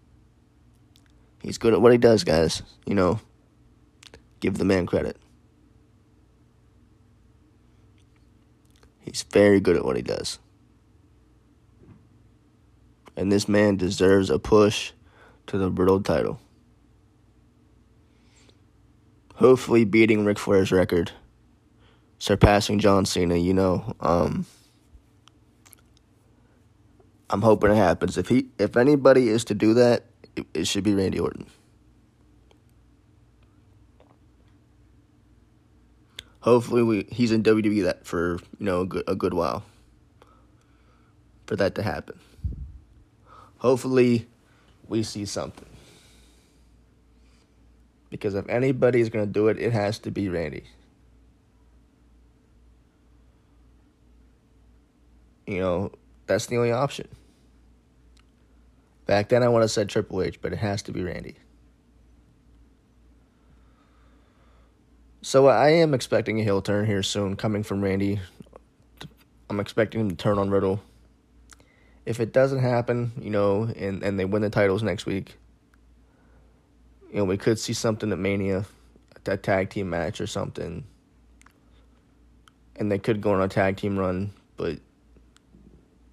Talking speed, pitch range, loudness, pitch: 115 wpm, 70-110 Hz, -23 LUFS, 100 Hz